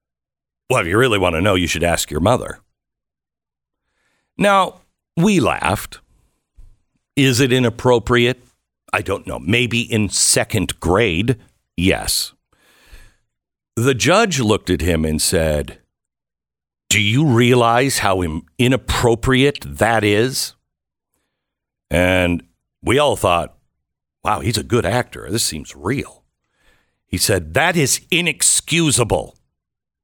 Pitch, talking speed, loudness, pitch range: 105 Hz, 115 wpm, -17 LUFS, 85-125 Hz